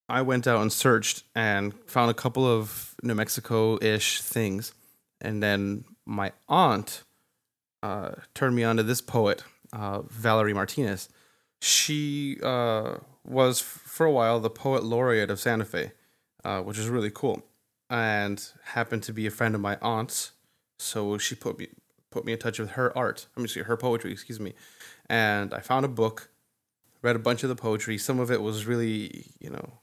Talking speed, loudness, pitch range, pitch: 180 wpm, -27 LUFS, 110-125 Hz, 115 Hz